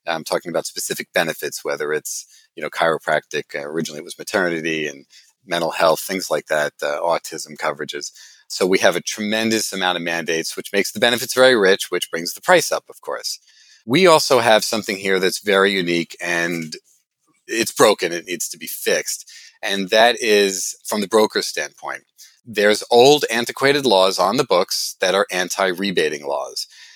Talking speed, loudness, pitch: 175 wpm, -19 LUFS, 110 Hz